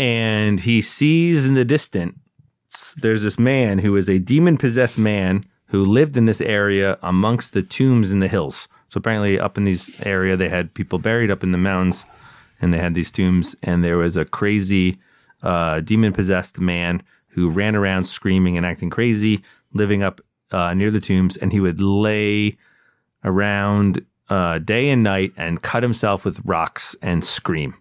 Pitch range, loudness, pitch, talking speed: 90-110 Hz, -19 LUFS, 100 Hz, 180 wpm